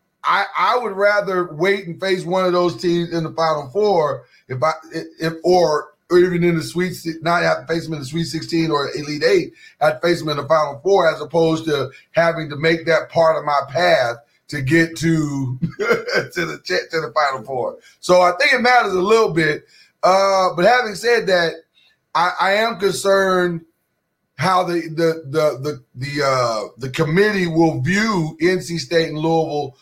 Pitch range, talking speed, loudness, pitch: 155-185 Hz, 195 wpm, -18 LUFS, 165 Hz